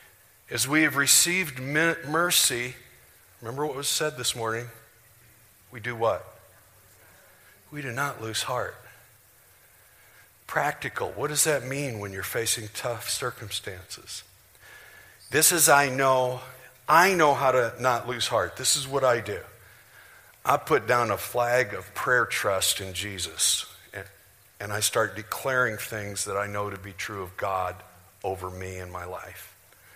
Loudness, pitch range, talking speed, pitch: -25 LUFS, 100-130 Hz, 150 wpm, 115 Hz